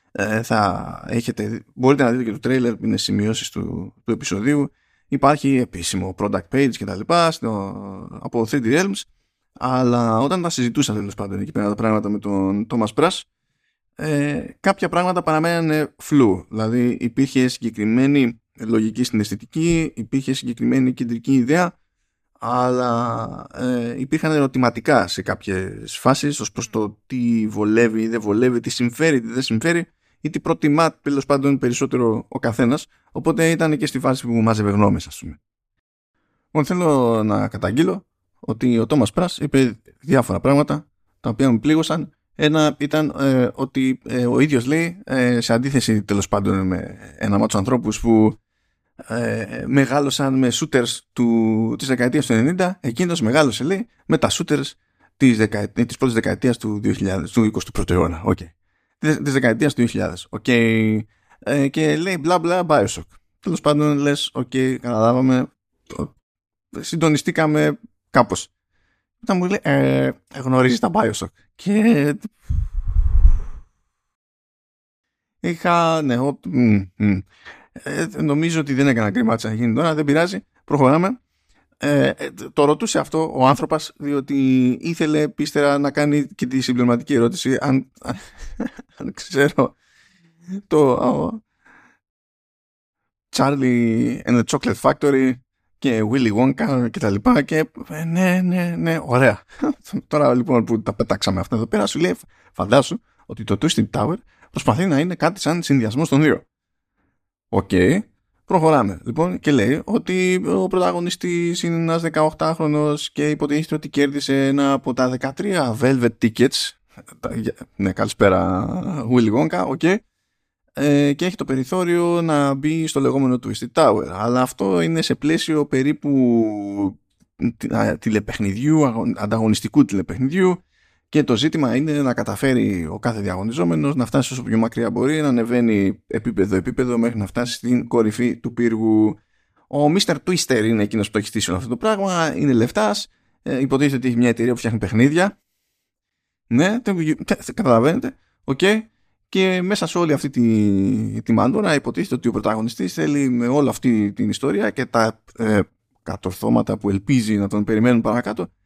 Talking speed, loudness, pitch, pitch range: 145 wpm, -19 LUFS, 130 Hz, 110-150 Hz